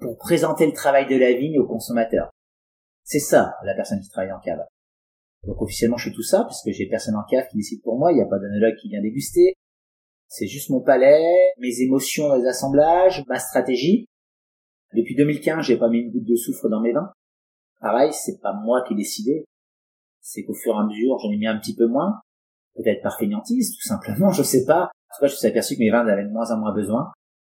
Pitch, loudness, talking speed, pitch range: 120 Hz, -21 LUFS, 230 wpm, 105-145 Hz